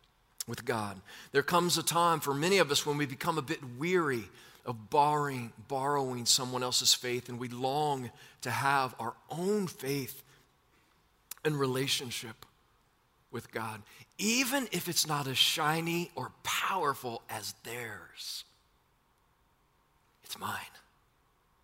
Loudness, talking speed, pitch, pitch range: -31 LUFS, 130 wpm, 140 Hz, 125-155 Hz